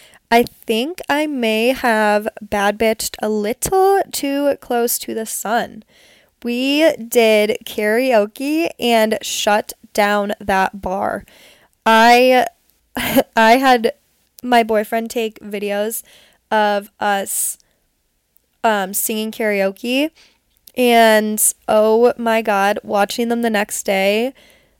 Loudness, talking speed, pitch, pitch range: -16 LUFS, 105 wpm, 225 Hz, 210-245 Hz